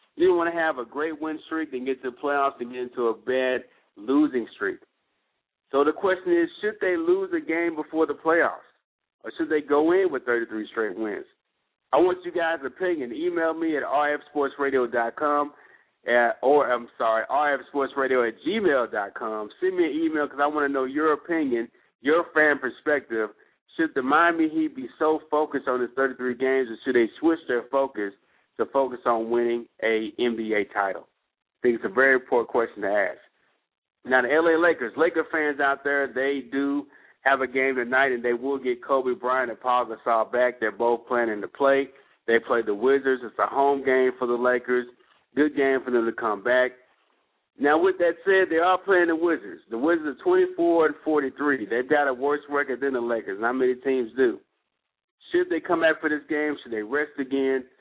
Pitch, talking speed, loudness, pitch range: 140 Hz, 200 wpm, -24 LUFS, 125-160 Hz